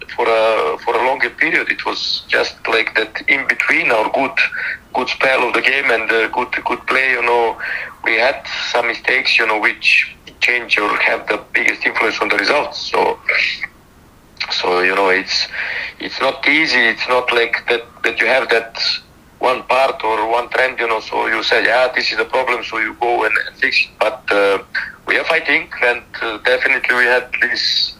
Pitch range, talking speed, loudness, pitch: 110-120 Hz, 195 wpm, -15 LUFS, 115 Hz